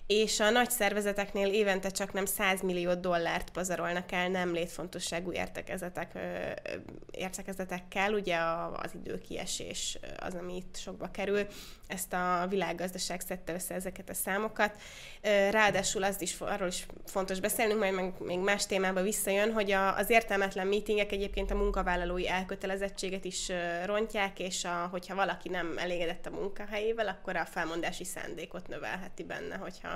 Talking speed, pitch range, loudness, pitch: 140 wpm, 180-200 Hz, -32 LUFS, 190 Hz